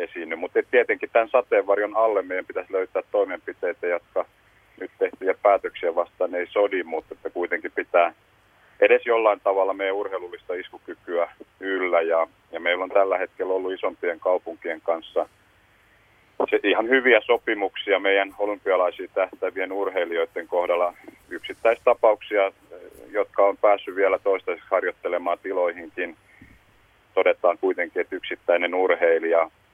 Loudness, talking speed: -23 LUFS, 120 wpm